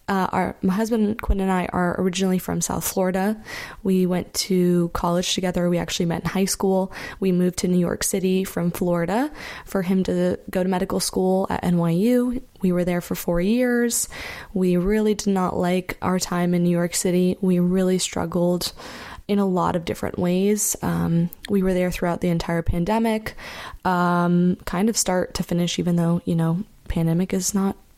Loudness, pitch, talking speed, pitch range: -22 LUFS, 185 Hz, 185 wpm, 175-195 Hz